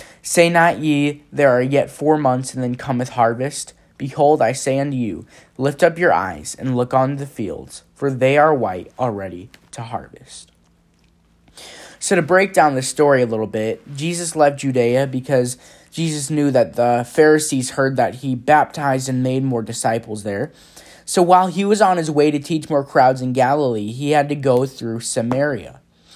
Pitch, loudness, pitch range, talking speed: 135 Hz, -18 LUFS, 125-150 Hz, 180 wpm